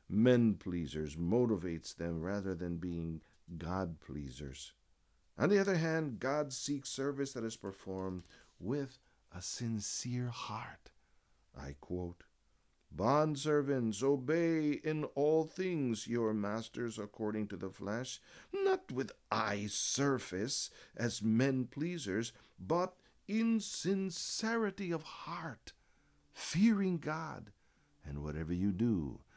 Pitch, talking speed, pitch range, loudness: 115 Hz, 110 wpm, 90-150 Hz, -36 LUFS